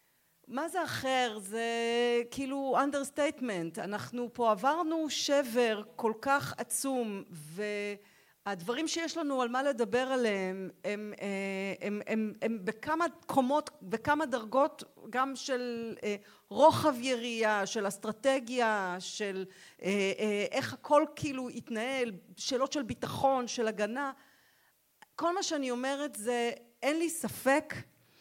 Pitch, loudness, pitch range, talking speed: 240 Hz, -32 LUFS, 210-275 Hz, 115 wpm